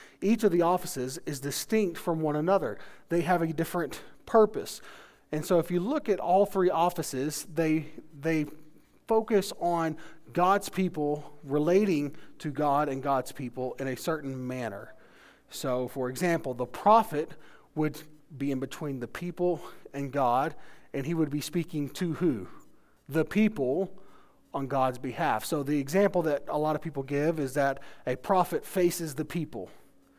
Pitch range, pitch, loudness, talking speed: 140-175 Hz, 155 Hz, -29 LUFS, 160 wpm